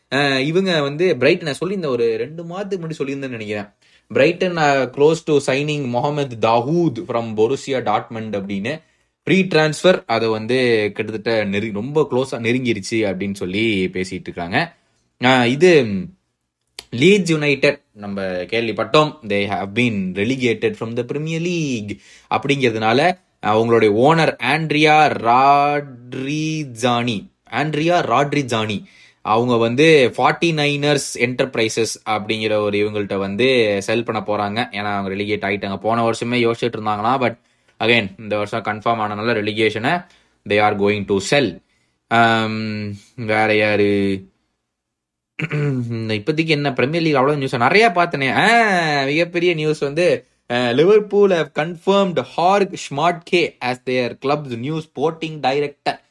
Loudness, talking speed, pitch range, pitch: -18 LUFS, 95 wpm, 110-150 Hz, 120 Hz